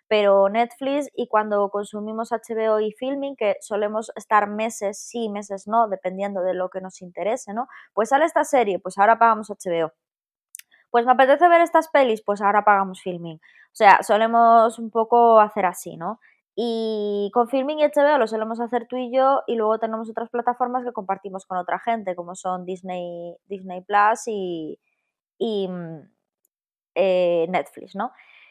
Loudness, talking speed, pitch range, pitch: -21 LUFS, 165 wpm, 190-235 Hz, 215 Hz